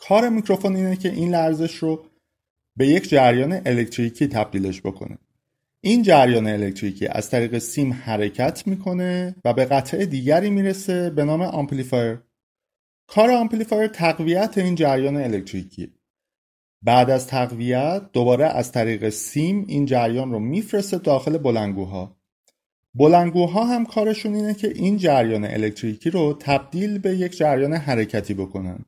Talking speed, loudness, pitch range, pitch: 130 wpm, -21 LUFS, 115-185 Hz, 140 Hz